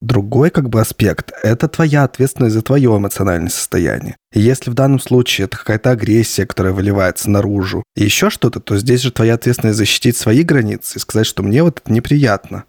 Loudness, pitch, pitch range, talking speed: -14 LUFS, 115 Hz, 100-130 Hz, 190 wpm